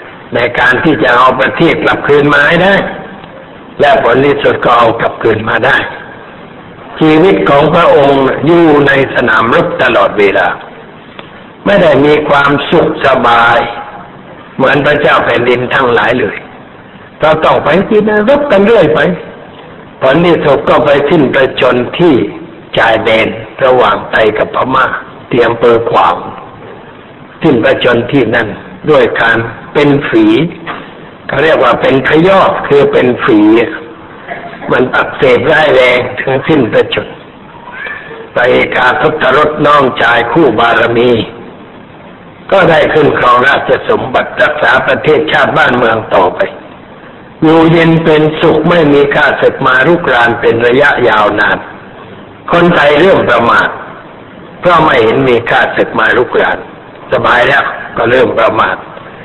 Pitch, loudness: 165 Hz, -8 LUFS